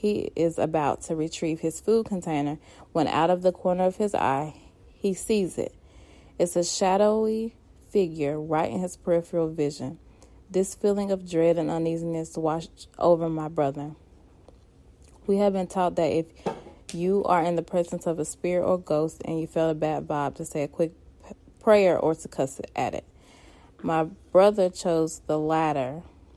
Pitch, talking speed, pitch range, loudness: 165 Hz, 170 wpm, 155-185 Hz, -26 LUFS